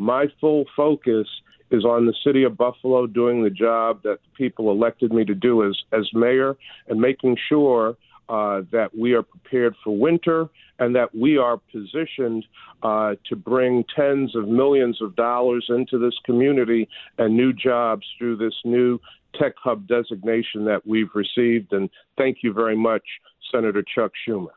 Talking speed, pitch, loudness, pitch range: 165 wpm, 120 Hz, -21 LUFS, 110-130 Hz